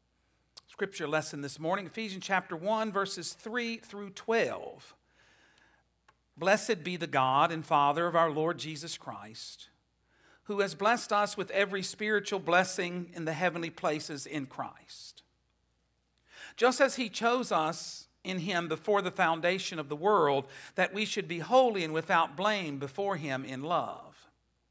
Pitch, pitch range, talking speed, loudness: 180 Hz, 155-205 Hz, 150 wpm, -31 LUFS